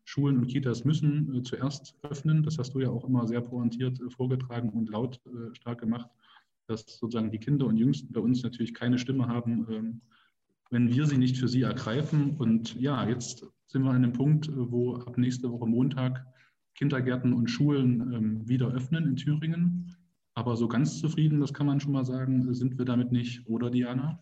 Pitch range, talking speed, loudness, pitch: 120-140 Hz, 200 wpm, -29 LUFS, 125 Hz